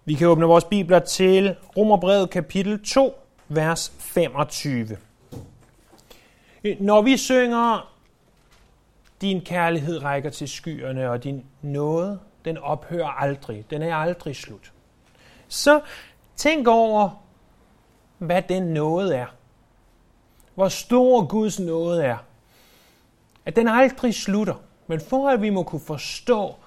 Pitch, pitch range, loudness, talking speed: 170 Hz, 140-205 Hz, -21 LUFS, 115 wpm